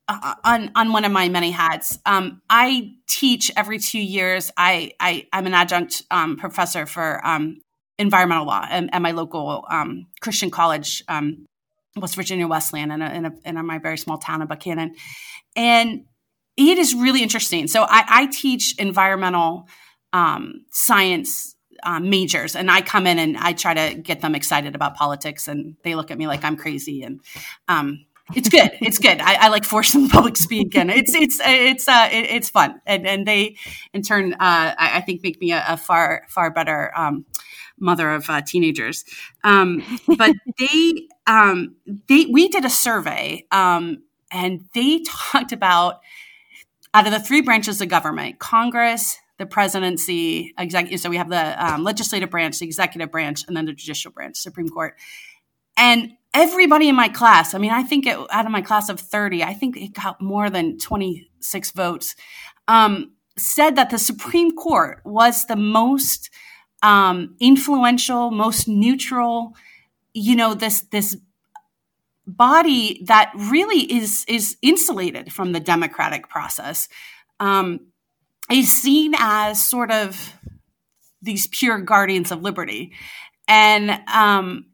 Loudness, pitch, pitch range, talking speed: -17 LUFS, 205 Hz, 175-240 Hz, 165 wpm